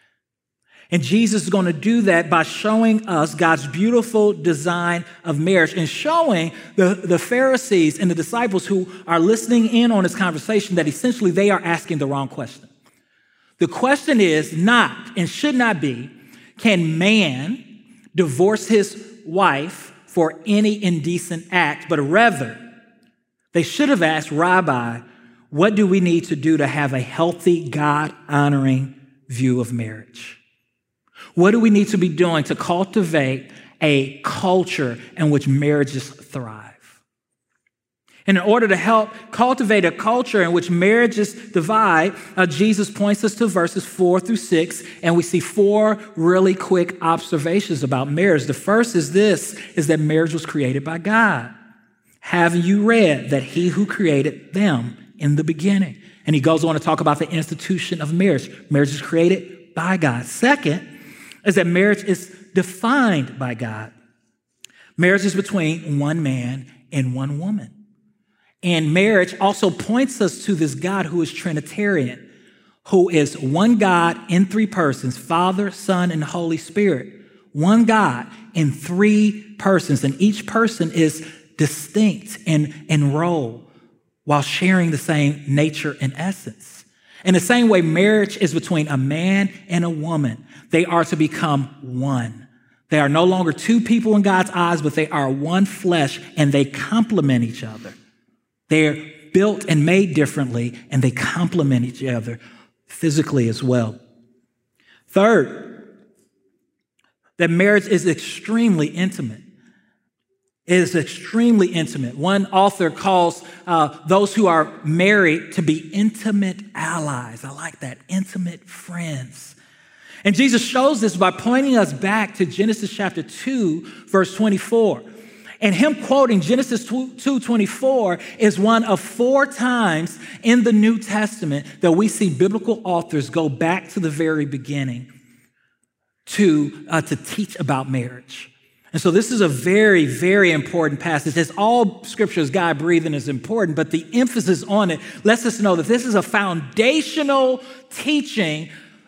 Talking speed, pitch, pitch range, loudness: 150 wpm, 180 Hz, 155-210 Hz, -18 LUFS